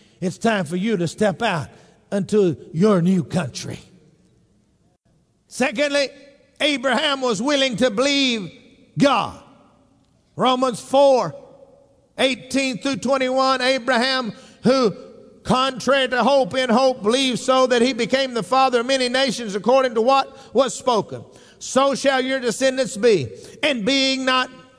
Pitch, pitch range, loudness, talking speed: 255 Hz, 225-265 Hz, -19 LUFS, 130 wpm